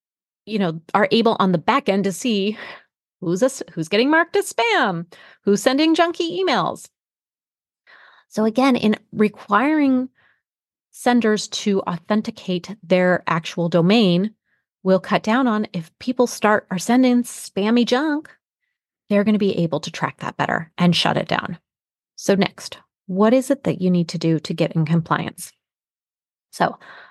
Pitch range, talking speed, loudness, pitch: 180-250 Hz, 155 wpm, -20 LUFS, 210 Hz